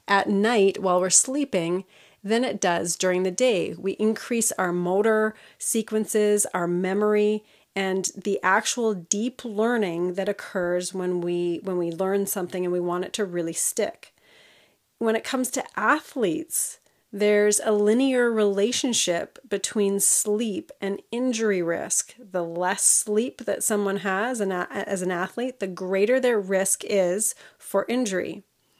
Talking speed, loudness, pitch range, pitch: 140 wpm, -24 LUFS, 185-225 Hz, 200 Hz